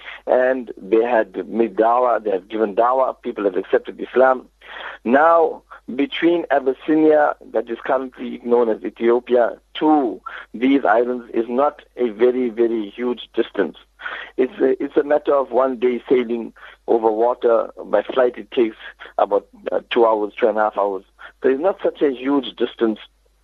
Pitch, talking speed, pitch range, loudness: 125 Hz, 160 wpm, 115-150 Hz, -19 LUFS